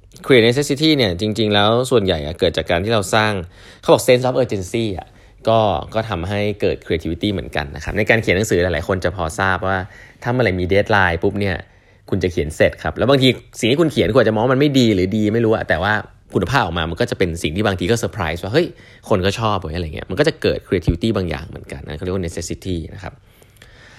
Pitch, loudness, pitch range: 100 Hz, -18 LUFS, 90-115 Hz